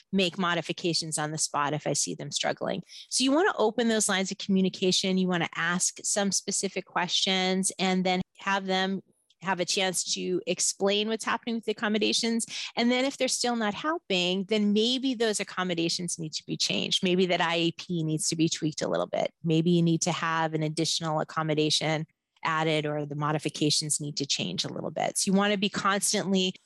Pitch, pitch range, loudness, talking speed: 185 Hz, 160-200 Hz, -27 LUFS, 200 wpm